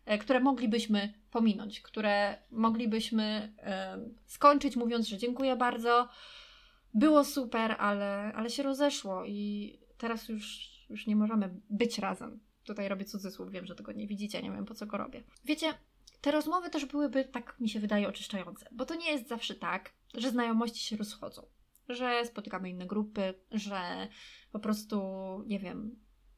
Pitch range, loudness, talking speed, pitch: 205-245 Hz, -33 LUFS, 155 wpm, 220 Hz